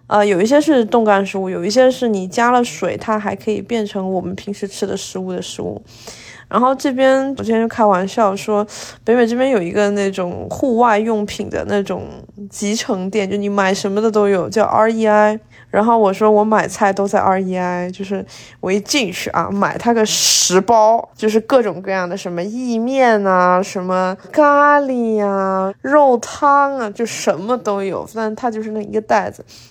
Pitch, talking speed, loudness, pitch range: 210 Hz, 275 characters per minute, -16 LUFS, 195-230 Hz